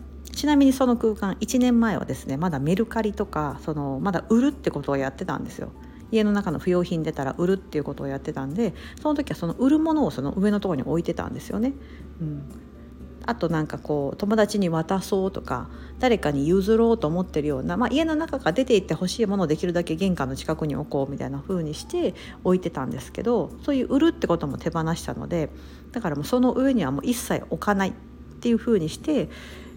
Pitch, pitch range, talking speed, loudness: 185 Hz, 150-230 Hz, 445 characters per minute, -25 LUFS